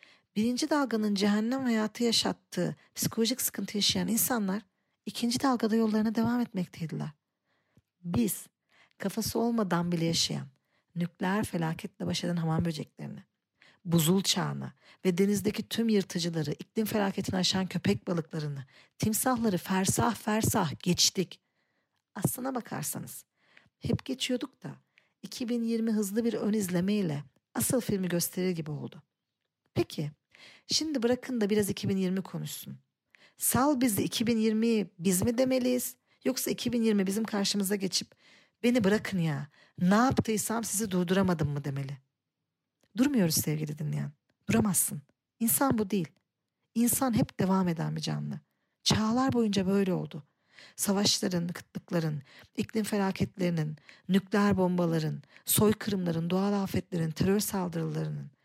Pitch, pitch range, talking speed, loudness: 195 Hz, 170-225 Hz, 115 wpm, -29 LUFS